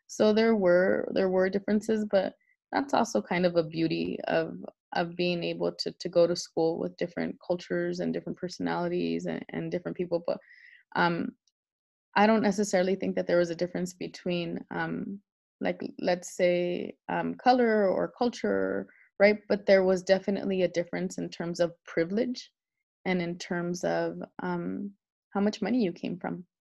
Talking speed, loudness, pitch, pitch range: 165 wpm, -29 LUFS, 180 Hz, 165-205 Hz